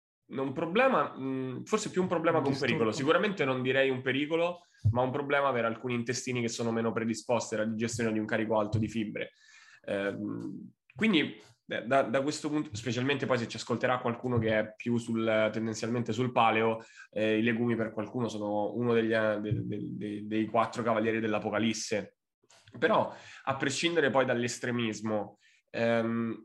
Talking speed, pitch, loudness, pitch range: 155 wpm, 115 Hz, -30 LUFS, 110-130 Hz